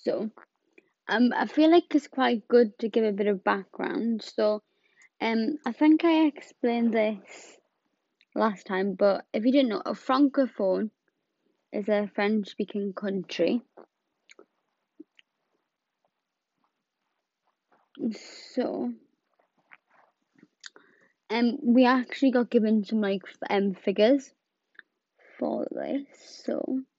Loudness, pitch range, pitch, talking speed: -26 LUFS, 210-280 Hz, 240 Hz, 105 wpm